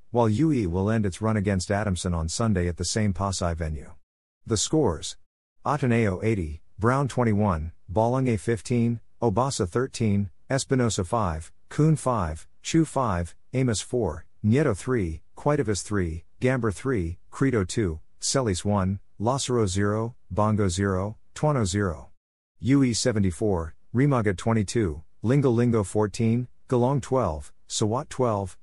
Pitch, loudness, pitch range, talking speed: 105 Hz, -26 LUFS, 90-120 Hz, 125 wpm